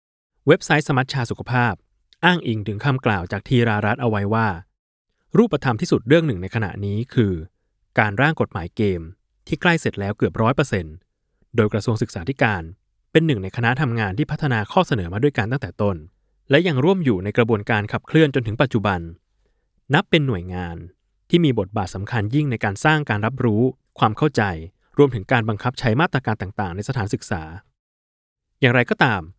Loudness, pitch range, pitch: -21 LUFS, 100-135 Hz, 115 Hz